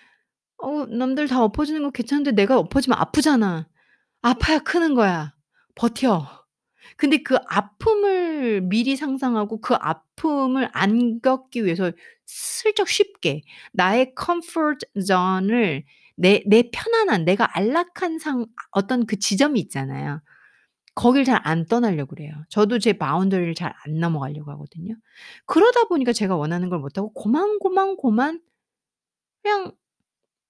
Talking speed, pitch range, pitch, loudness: 270 characters per minute, 185-295 Hz, 235 Hz, -21 LUFS